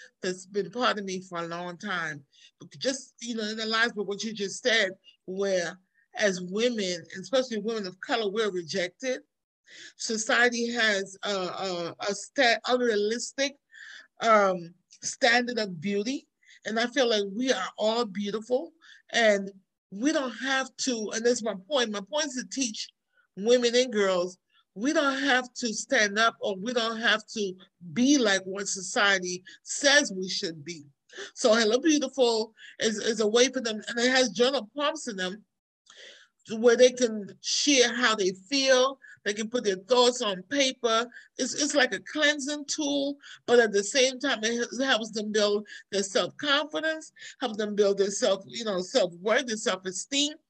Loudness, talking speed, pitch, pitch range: -27 LUFS, 170 wpm, 225 Hz, 200-255 Hz